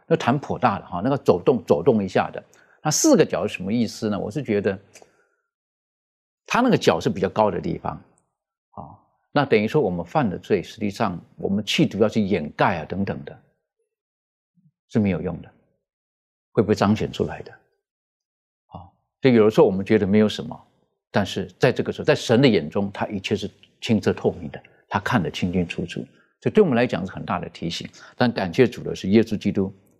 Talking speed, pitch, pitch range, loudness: 290 characters per minute, 105 Hz, 95-125 Hz, -22 LUFS